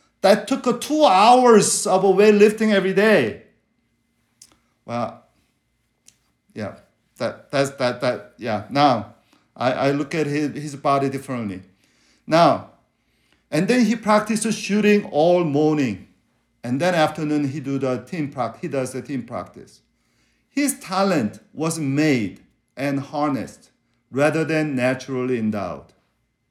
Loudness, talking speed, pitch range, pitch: -20 LUFS, 125 wpm, 130-200 Hz, 150 Hz